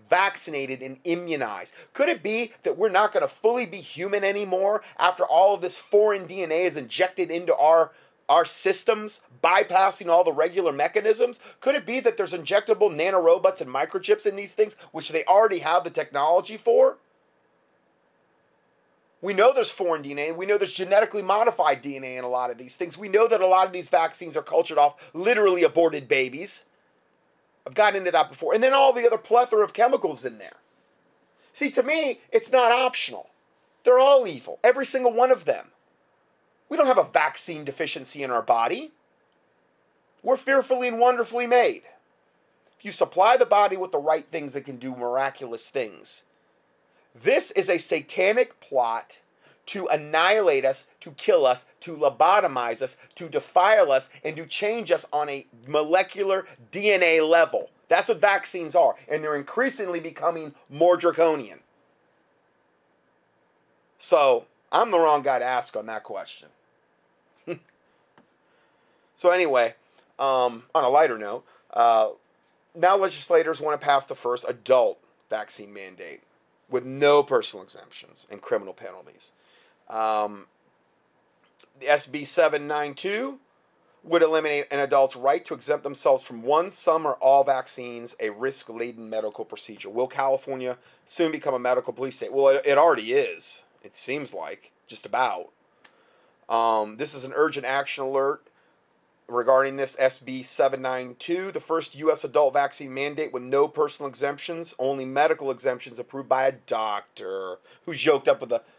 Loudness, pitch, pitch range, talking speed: -23 LUFS, 165 Hz, 135-210 Hz, 155 wpm